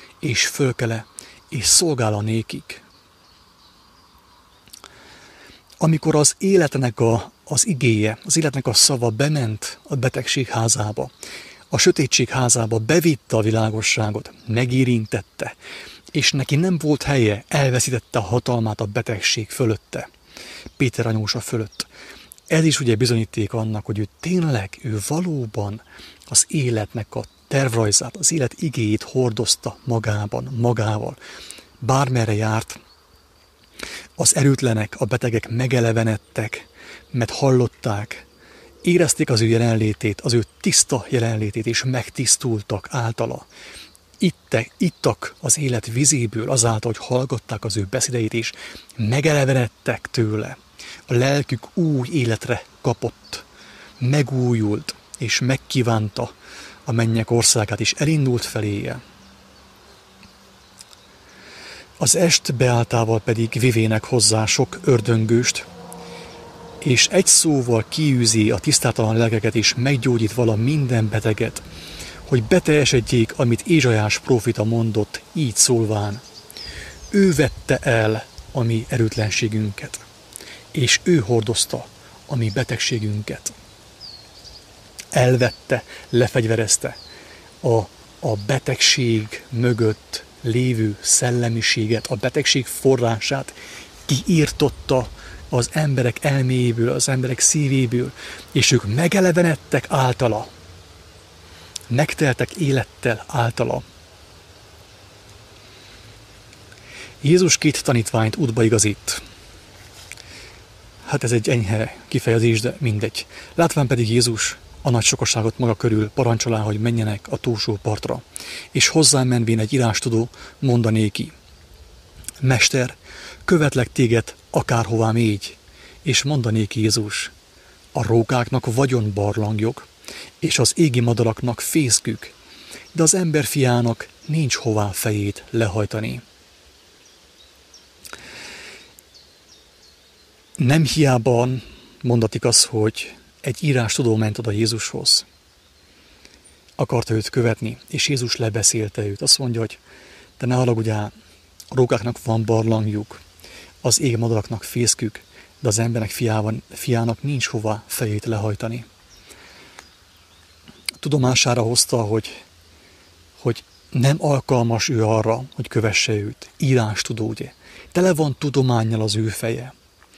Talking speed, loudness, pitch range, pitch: 105 wpm, -19 LUFS, 110-130 Hz, 115 Hz